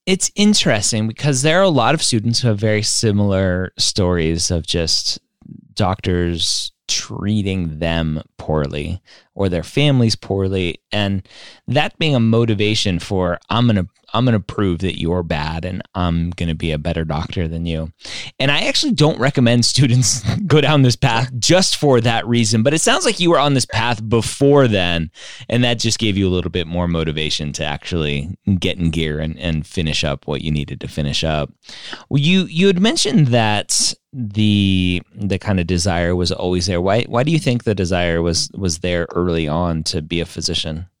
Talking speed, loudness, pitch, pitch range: 190 wpm, -17 LUFS, 100 Hz, 85-120 Hz